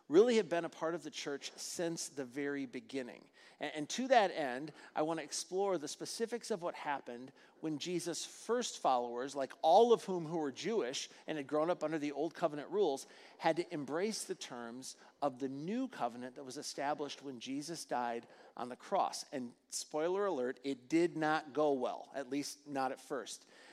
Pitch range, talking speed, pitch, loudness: 135-175 Hz, 195 wpm, 150 Hz, -37 LUFS